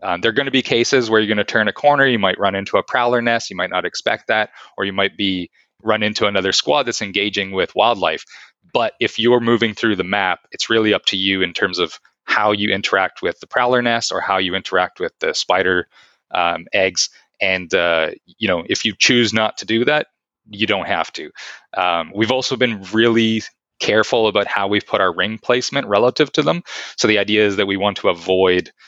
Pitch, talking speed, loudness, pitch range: 110 Hz, 225 wpm, -17 LUFS, 100-120 Hz